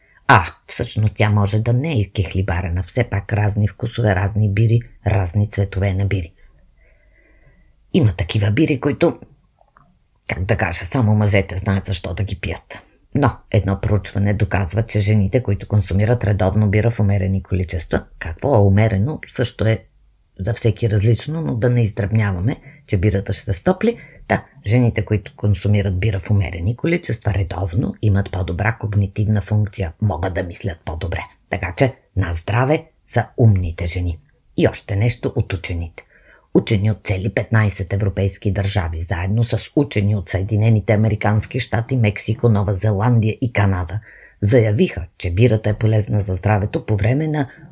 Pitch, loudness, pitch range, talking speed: 105 Hz, -19 LUFS, 95-115 Hz, 150 wpm